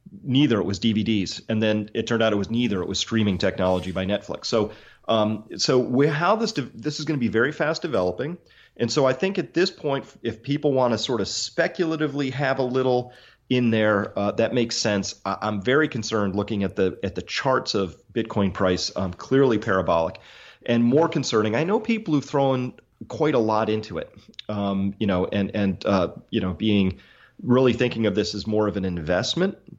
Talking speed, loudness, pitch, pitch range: 205 wpm, -23 LUFS, 115 Hz, 100-135 Hz